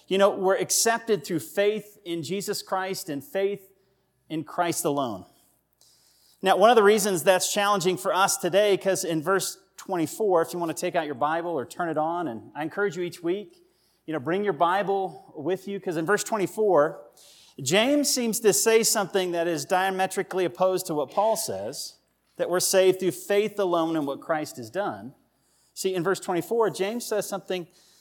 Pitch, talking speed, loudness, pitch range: 190 Hz, 190 wpm, -25 LUFS, 170-200 Hz